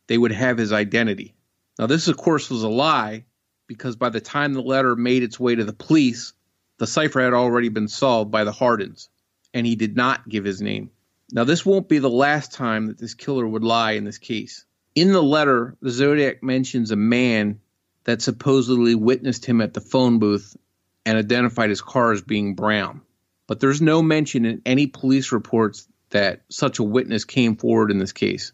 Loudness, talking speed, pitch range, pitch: -20 LUFS, 200 wpm, 110-130 Hz, 120 Hz